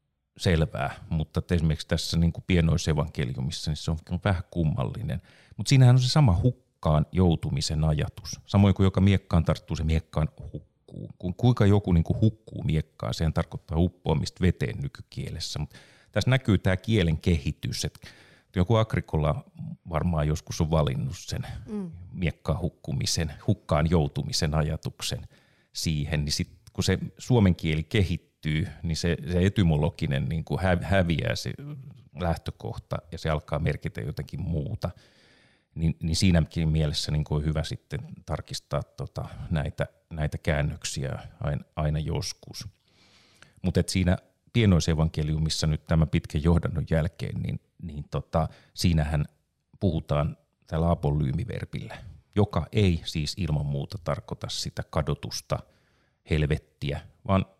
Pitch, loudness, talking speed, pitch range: 85 Hz, -27 LUFS, 125 wpm, 80-100 Hz